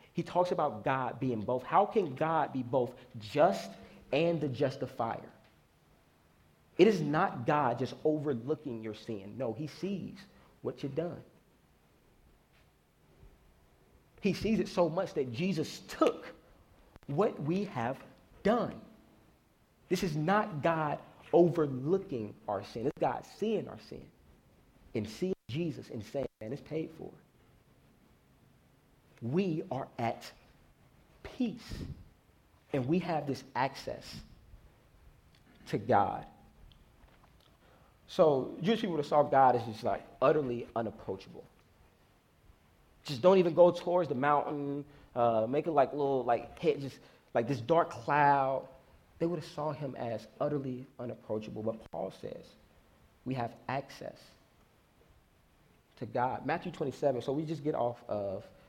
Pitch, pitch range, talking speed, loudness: 140 Hz, 115-165 Hz, 130 wpm, -33 LUFS